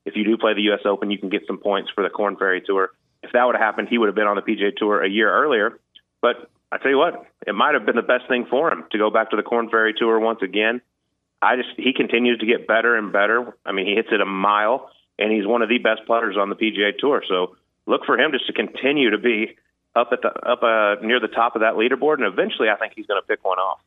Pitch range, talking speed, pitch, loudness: 105-115 Hz, 285 wpm, 110 Hz, -20 LUFS